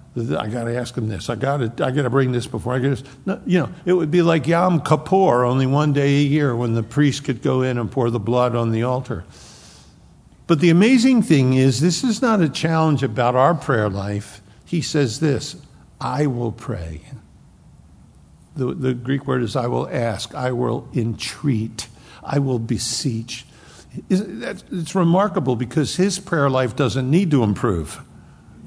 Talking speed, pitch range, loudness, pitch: 180 wpm, 120-155 Hz, -20 LUFS, 130 Hz